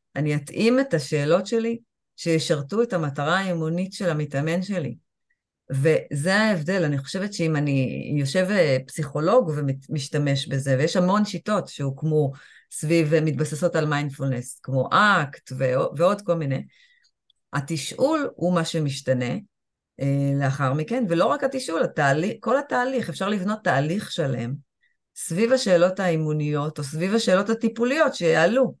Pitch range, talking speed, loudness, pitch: 145-195 Hz, 120 wpm, -23 LUFS, 165 Hz